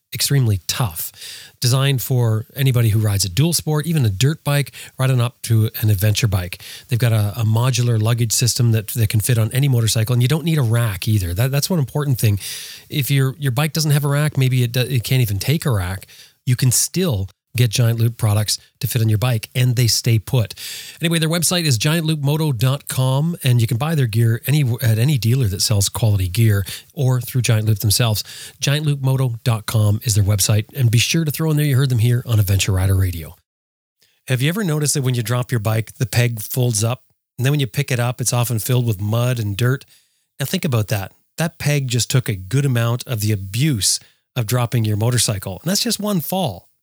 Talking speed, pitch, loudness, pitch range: 220 wpm, 125 Hz, -18 LUFS, 110-140 Hz